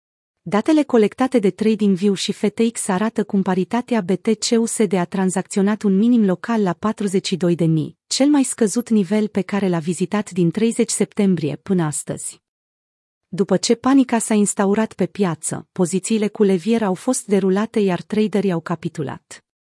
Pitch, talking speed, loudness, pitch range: 205 Hz, 145 wpm, -19 LUFS, 185-220 Hz